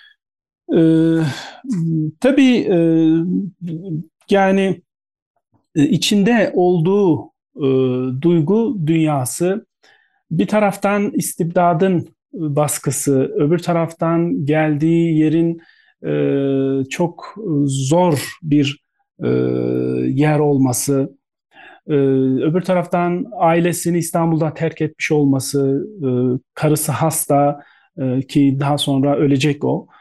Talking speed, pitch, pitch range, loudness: 80 wpm, 155 Hz, 140-175 Hz, -17 LUFS